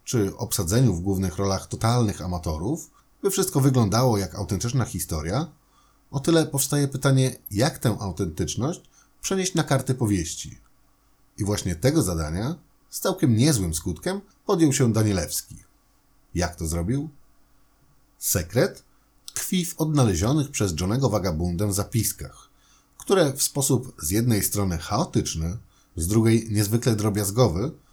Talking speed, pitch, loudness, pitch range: 125 wpm, 115 Hz, -24 LUFS, 95-140 Hz